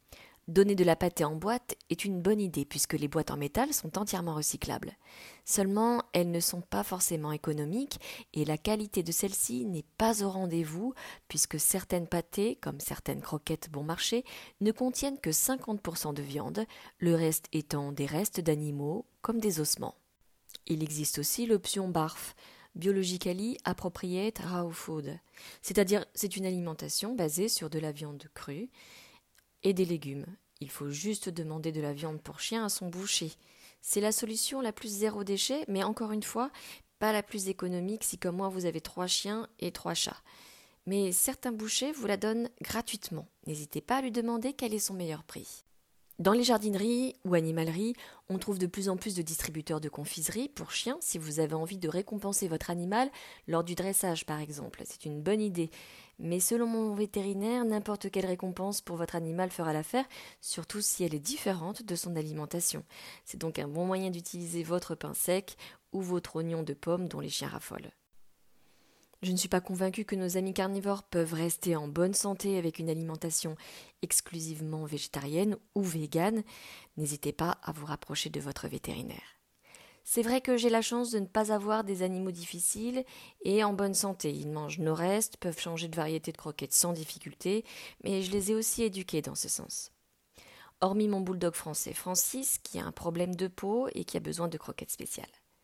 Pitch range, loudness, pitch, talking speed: 160-210 Hz, -32 LUFS, 185 Hz, 180 wpm